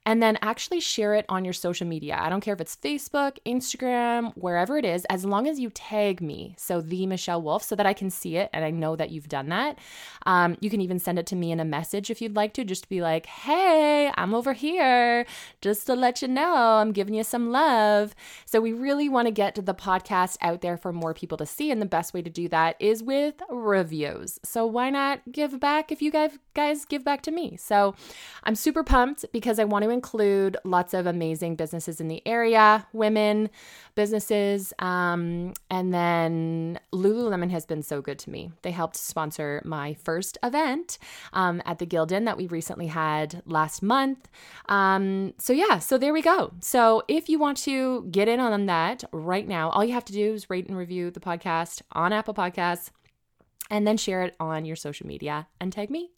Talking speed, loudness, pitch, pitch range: 215 wpm, -25 LUFS, 200 Hz, 175-240 Hz